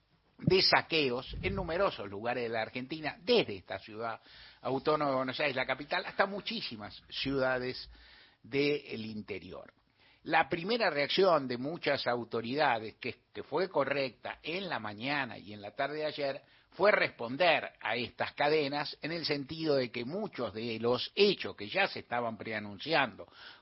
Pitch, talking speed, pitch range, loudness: 135 Hz, 150 wpm, 115-155 Hz, -32 LUFS